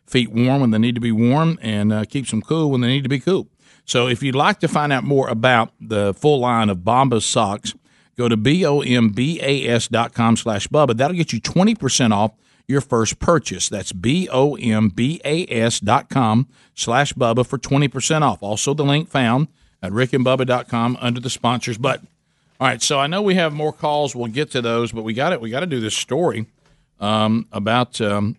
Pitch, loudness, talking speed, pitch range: 125 Hz, -19 LUFS, 230 wpm, 115-145 Hz